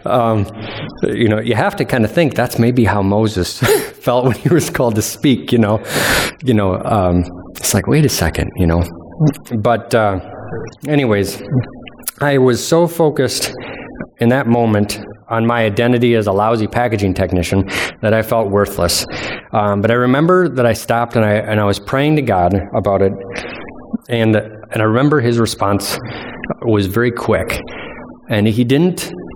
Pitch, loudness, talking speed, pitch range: 115 Hz, -15 LUFS, 170 wpm, 105-125 Hz